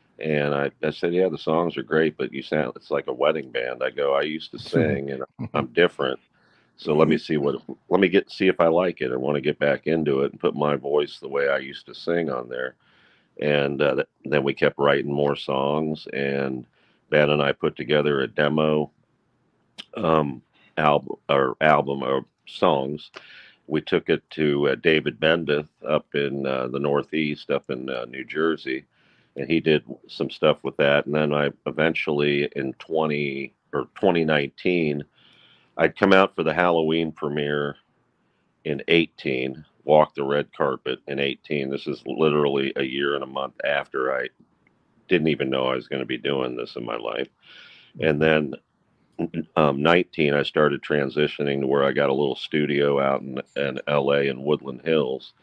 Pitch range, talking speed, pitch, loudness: 70-75 Hz, 185 wpm, 75 Hz, -23 LUFS